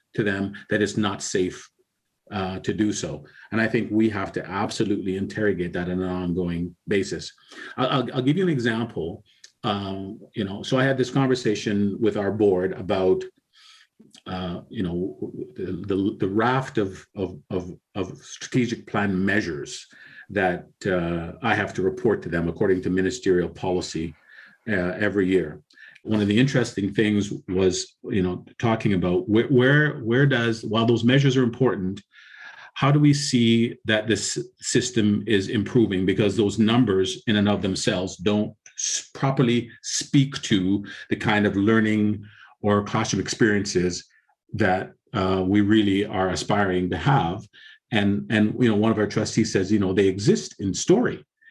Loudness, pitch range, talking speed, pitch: -23 LUFS, 95-115 Hz, 160 wpm, 105 Hz